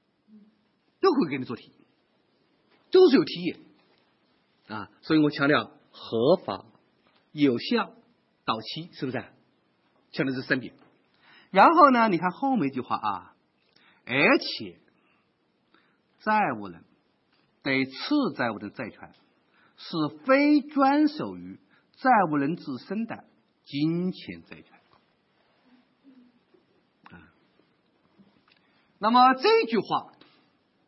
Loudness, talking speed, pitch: -25 LUFS, 145 characters per minute, 200 Hz